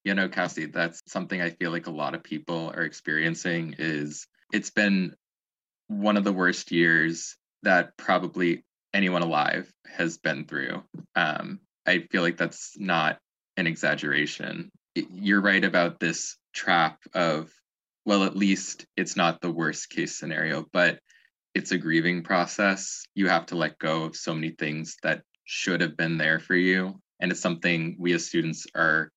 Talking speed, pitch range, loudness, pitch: 165 wpm, 80-95 Hz, -26 LUFS, 85 Hz